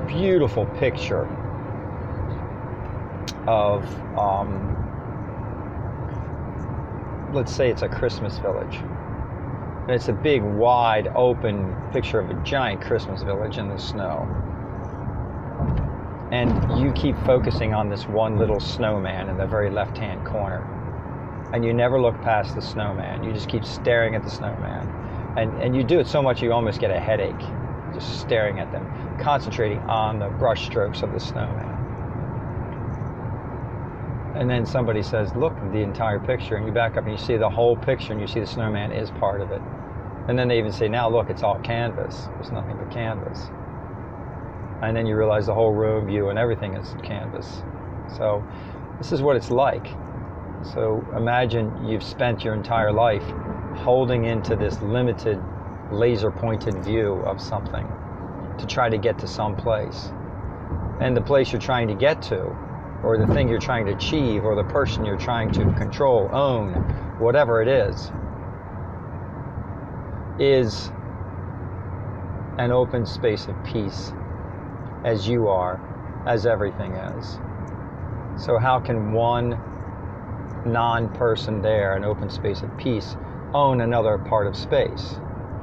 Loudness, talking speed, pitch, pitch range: -24 LUFS, 150 wpm, 110 Hz, 100-120 Hz